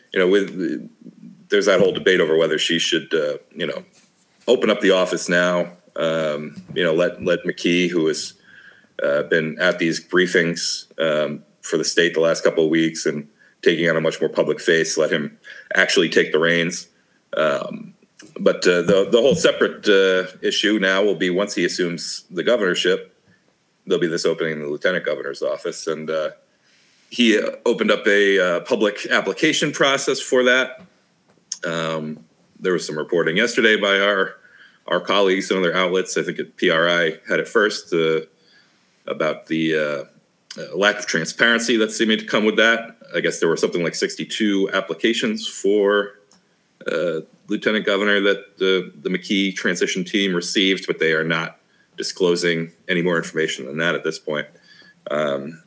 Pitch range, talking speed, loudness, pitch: 80-105 Hz, 170 wpm, -20 LUFS, 95 Hz